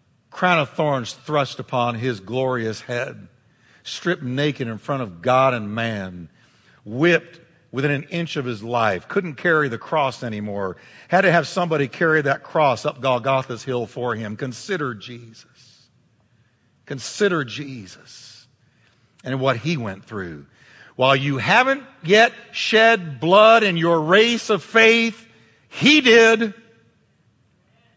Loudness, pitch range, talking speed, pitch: -19 LUFS, 120-170 Hz, 135 wpm, 135 Hz